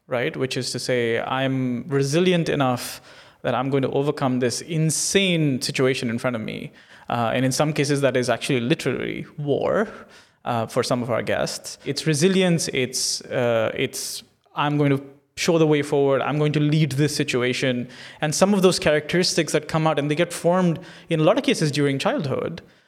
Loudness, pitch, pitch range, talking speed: -22 LUFS, 145 Hz, 130-160 Hz, 190 wpm